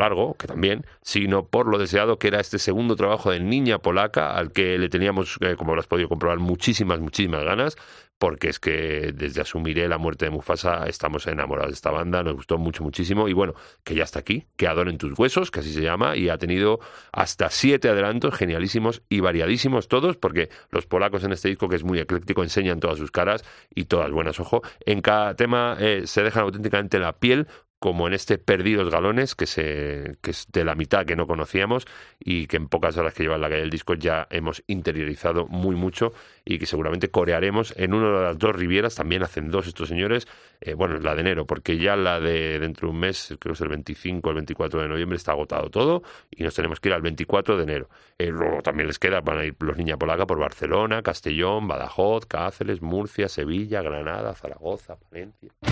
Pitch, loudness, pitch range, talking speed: 90 Hz, -24 LUFS, 80-100 Hz, 215 wpm